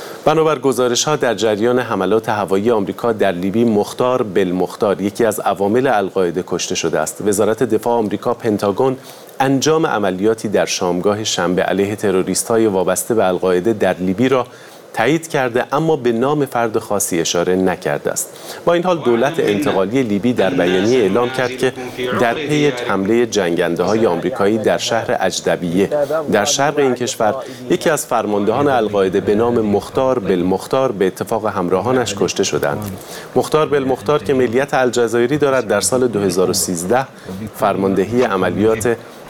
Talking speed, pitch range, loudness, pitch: 145 wpm, 95-130 Hz, -16 LUFS, 115 Hz